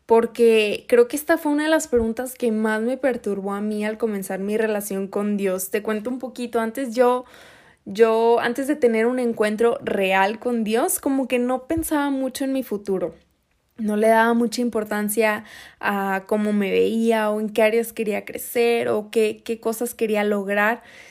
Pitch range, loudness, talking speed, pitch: 210-245 Hz, -22 LUFS, 185 wpm, 225 Hz